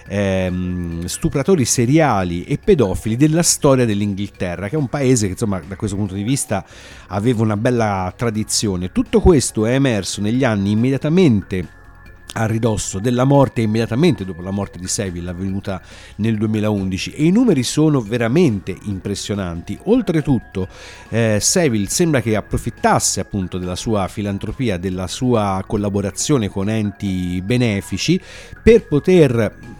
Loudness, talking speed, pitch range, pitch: -18 LUFS, 135 wpm, 95-125 Hz, 105 Hz